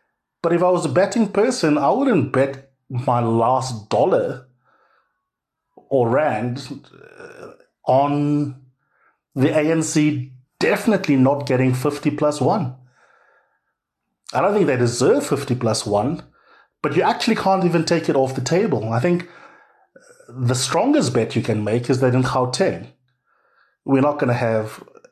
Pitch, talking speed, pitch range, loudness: 140 Hz, 145 wpm, 125-170 Hz, -19 LUFS